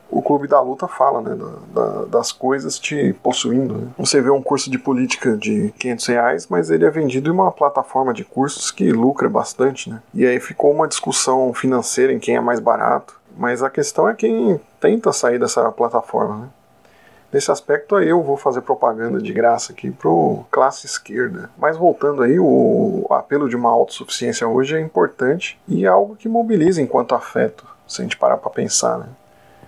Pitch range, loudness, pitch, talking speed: 120-160 Hz, -18 LUFS, 135 Hz, 190 wpm